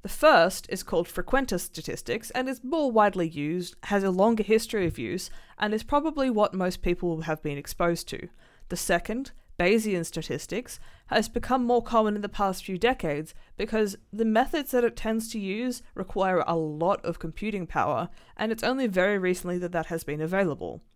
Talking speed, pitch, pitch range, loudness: 185 wpm, 195 Hz, 175-225 Hz, -27 LUFS